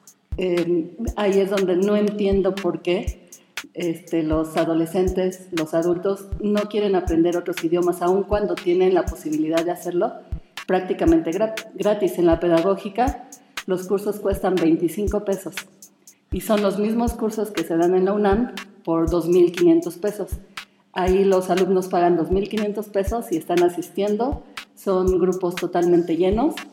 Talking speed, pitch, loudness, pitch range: 140 wpm, 190 Hz, -21 LUFS, 175-210 Hz